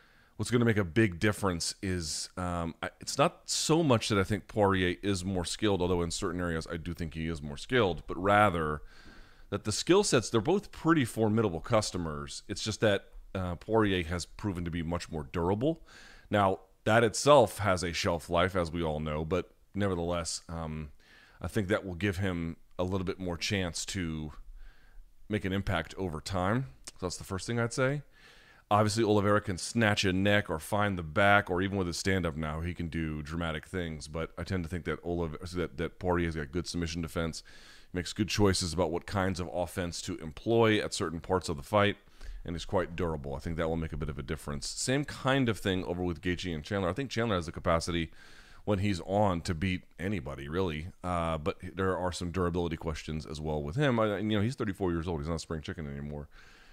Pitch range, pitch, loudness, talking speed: 85-105 Hz, 90 Hz, -31 LUFS, 215 wpm